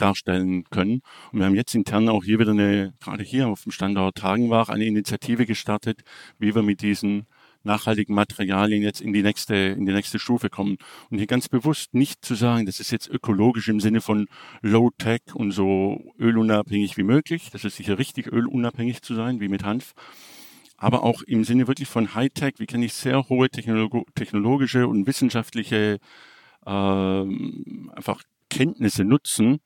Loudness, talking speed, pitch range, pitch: -23 LUFS, 175 wpm, 100-120 Hz, 110 Hz